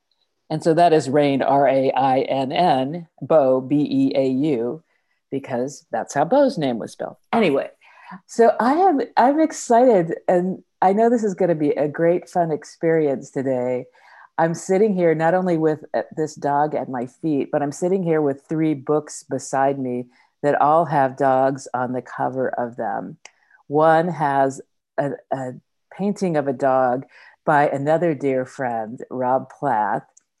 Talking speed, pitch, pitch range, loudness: 165 wpm, 150 Hz, 135-175 Hz, -20 LUFS